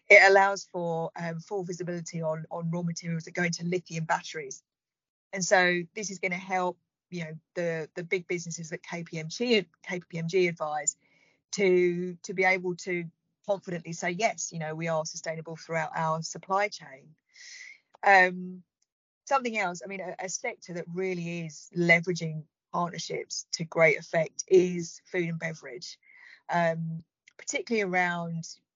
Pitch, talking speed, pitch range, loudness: 175 Hz, 150 wpm, 165-190 Hz, -28 LUFS